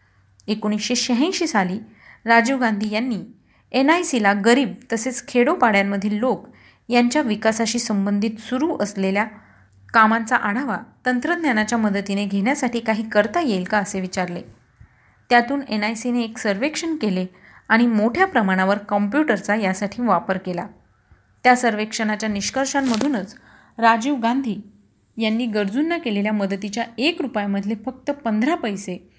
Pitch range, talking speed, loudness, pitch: 205-250 Hz, 115 wpm, -20 LUFS, 220 Hz